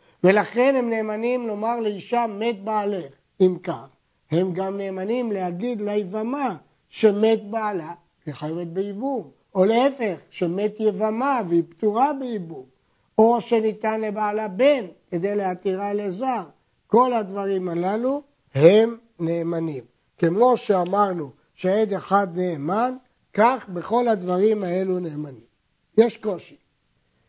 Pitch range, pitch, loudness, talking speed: 175-225 Hz, 205 Hz, -23 LUFS, 110 wpm